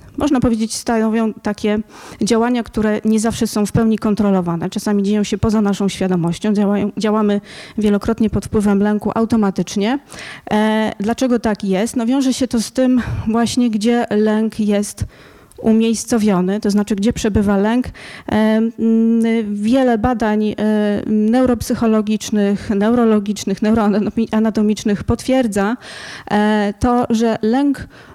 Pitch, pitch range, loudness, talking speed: 220 Hz, 210-230 Hz, -16 LUFS, 110 wpm